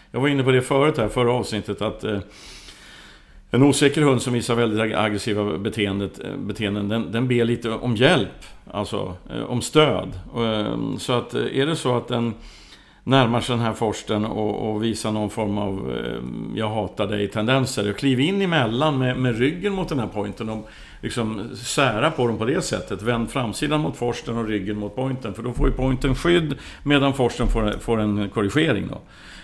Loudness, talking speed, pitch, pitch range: -22 LUFS, 180 wpm, 115 Hz, 105-130 Hz